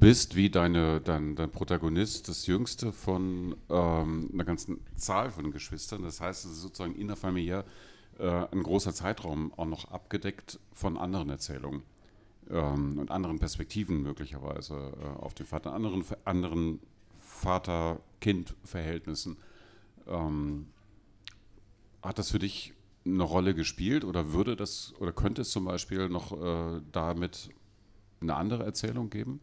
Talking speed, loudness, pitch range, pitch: 135 wpm, -33 LUFS, 80-100 Hz, 90 Hz